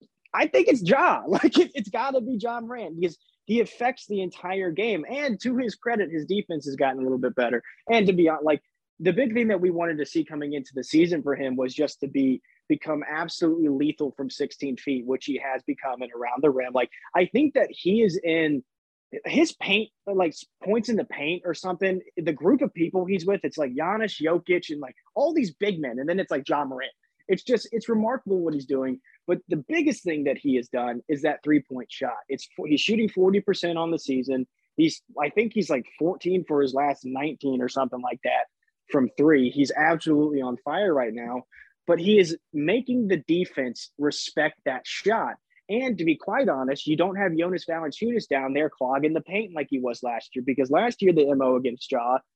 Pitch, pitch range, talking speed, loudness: 165 Hz, 140-205 Hz, 220 wpm, -25 LUFS